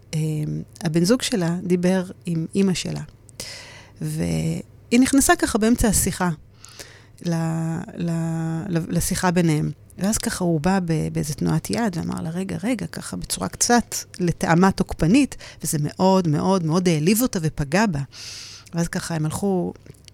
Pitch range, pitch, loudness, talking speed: 150-190 Hz, 170 Hz, -22 LUFS, 135 wpm